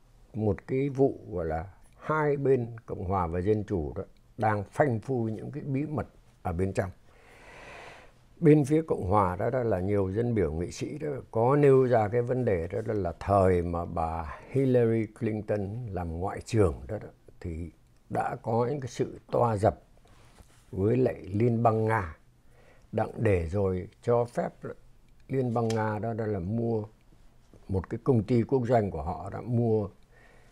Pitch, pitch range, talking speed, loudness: 110 Hz, 95-120 Hz, 180 wpm, -28 LUFS